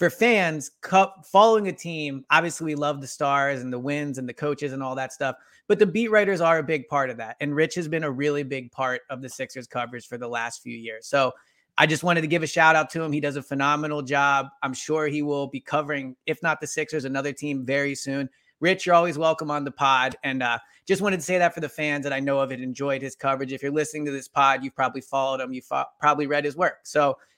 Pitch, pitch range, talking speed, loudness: 145 Hz, 135-160 Hz, 265 wpm, -24 LUFS